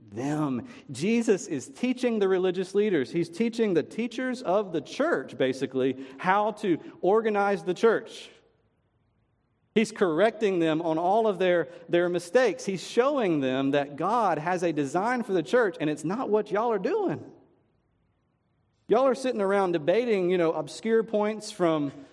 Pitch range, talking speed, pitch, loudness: 160-225 Hz, 155 wpm, 190 Hz, -26 LUFS